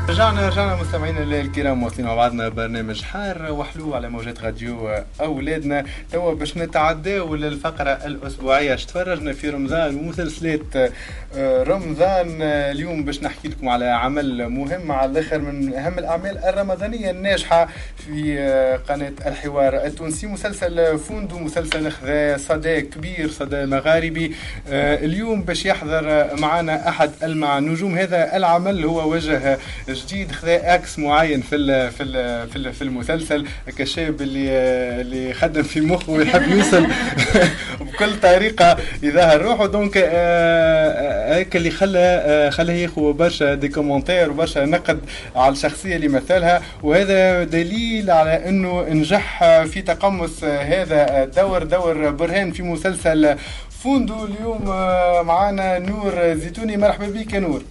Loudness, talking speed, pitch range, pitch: -19 LUFS, 130 wpm, 140-180 Hz, 160 Hz